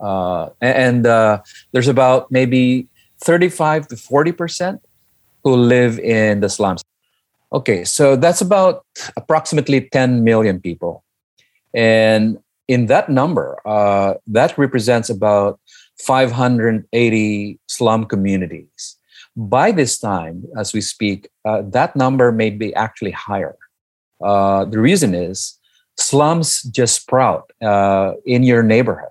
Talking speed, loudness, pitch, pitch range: 120 wpm, -15 LUFS, 115 Hz, 105-130 Hz